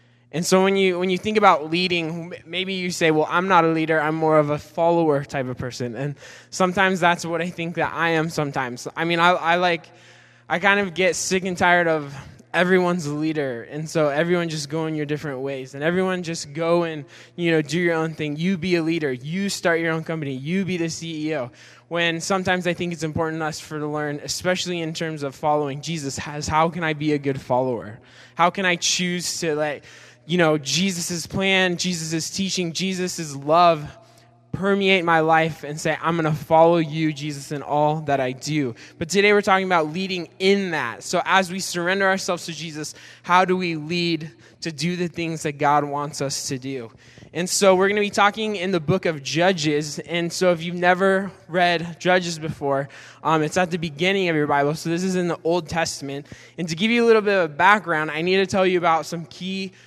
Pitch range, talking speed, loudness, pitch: 150-180 Hz, 220 wpm, -21 LUFS, 165 Hz